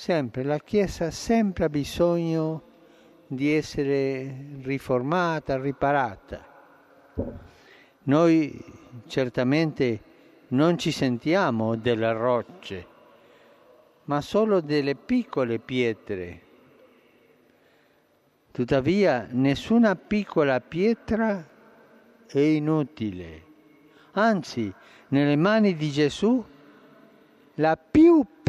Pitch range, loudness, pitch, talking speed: 130-175 Hz, -24 LUFS, 150 Hz, 75 wpm